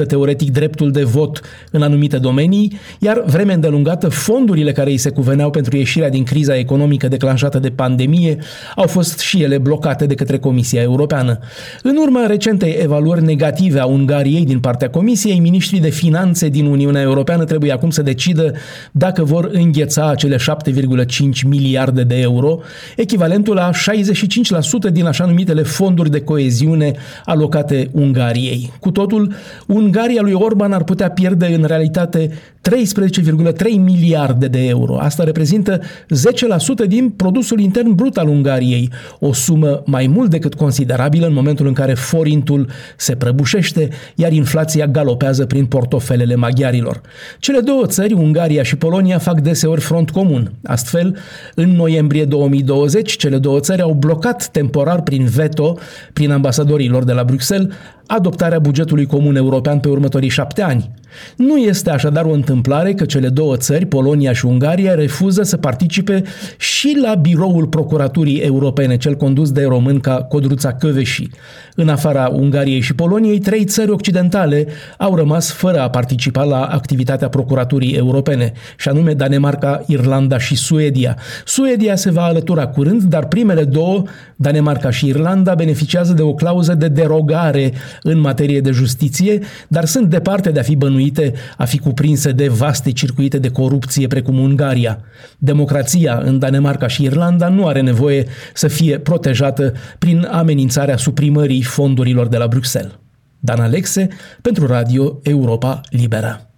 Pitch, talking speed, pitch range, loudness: 150 Hz, 145 wpm, 135-175 Hz, -14 LUFS